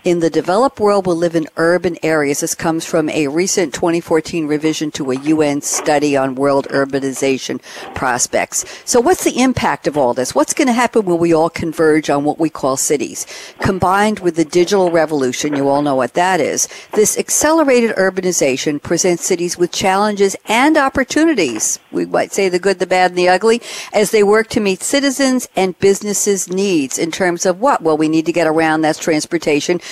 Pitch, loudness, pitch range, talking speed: 175 Hz, -15 LUFS, 155-205 Hz, 195 wpm